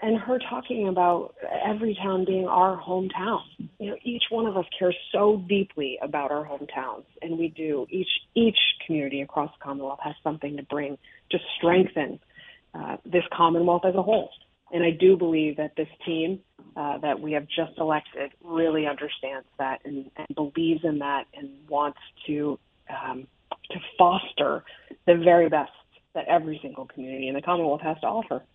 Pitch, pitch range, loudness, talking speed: 160 Hz, 145-185 Hz, -26 LUFS, 170 wpm